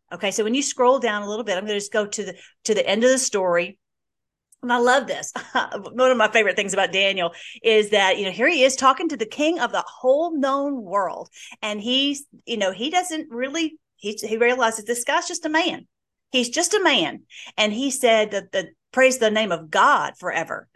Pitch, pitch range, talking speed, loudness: 240 Hz, 210-275 Hz, 230 wpm, -21 LUFS